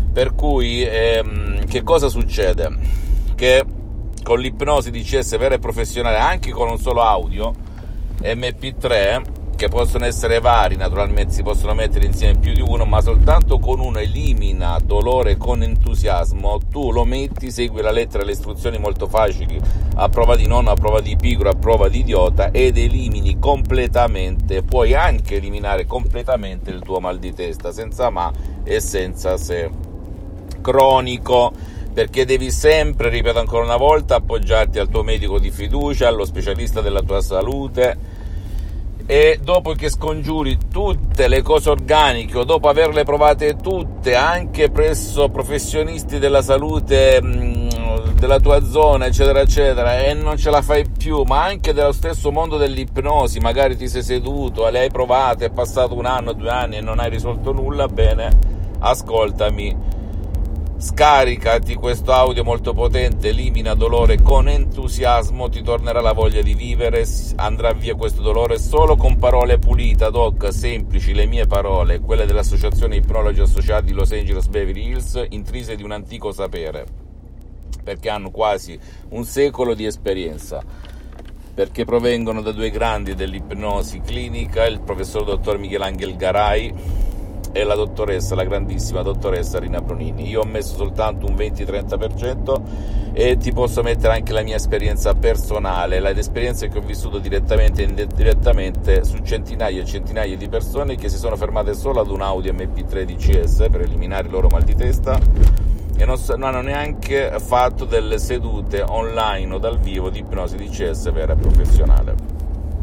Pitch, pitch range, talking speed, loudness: 100 Hz, 85-120 Hz, 155 wpm, -18 LUFS